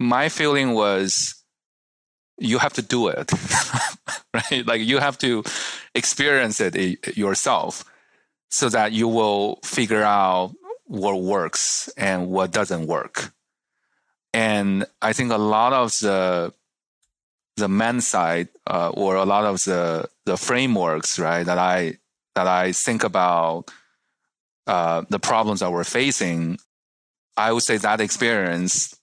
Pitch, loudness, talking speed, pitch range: 100 Hz, -21 LUFS, 130 wpm, 90-110 Hz